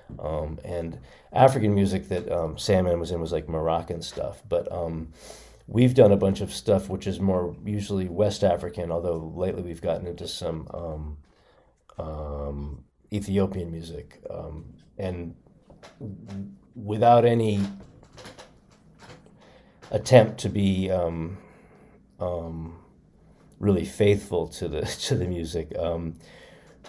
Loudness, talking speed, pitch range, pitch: -25 LUFS, 125 wpm, 85-100 Hz, 90 Hz